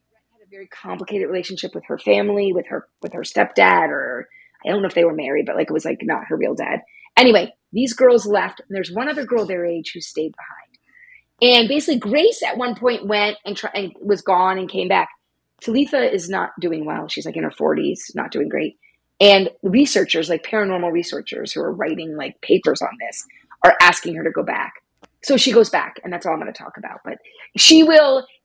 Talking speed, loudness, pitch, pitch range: 215 wpm, -18 LUFS, 210 Hz, 185-265 Hz